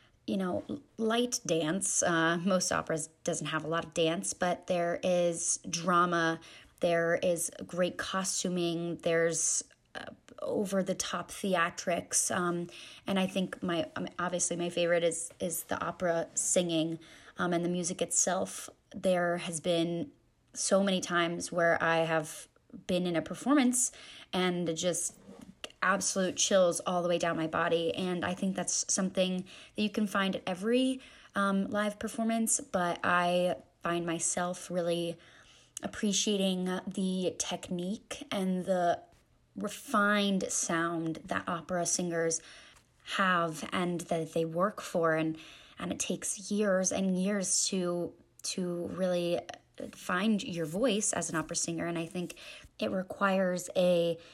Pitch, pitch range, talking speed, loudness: 175 Hz, 170-190 Hz, 140 wpm, -31 LUFS